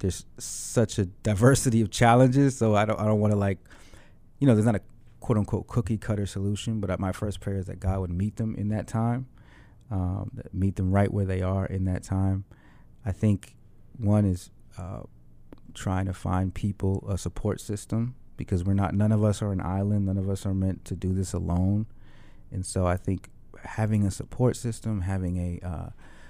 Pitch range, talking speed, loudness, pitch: 95-110 Hz, 205 wpm, -27 LUFS, 100 Hz